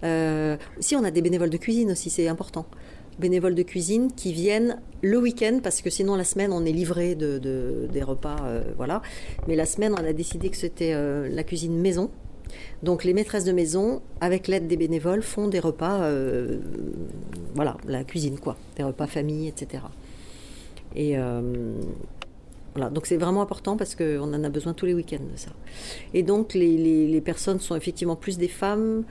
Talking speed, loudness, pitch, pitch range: 190 wpm, -26 LUFS, 170 Hz, 150-190 Hz